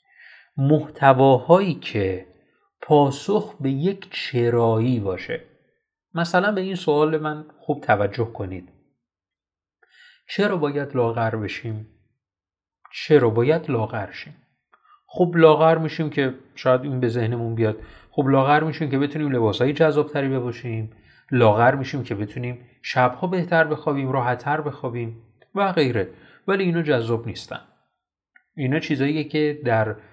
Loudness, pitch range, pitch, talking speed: -21 LUFS, 115-155 Hz, 140 Hz, 120 wpm